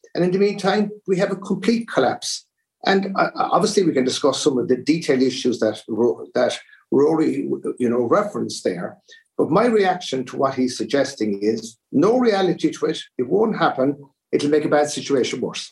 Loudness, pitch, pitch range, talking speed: -20 LUFS, 150 Hz, 125-200 Hz, 175 wpm